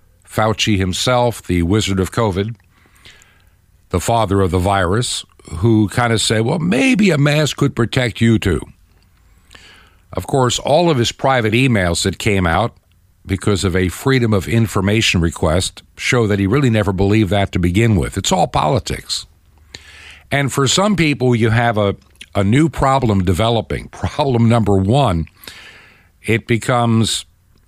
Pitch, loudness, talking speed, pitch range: 105 Hz, -16 LUFS, 150 wpm, 95-120 Hz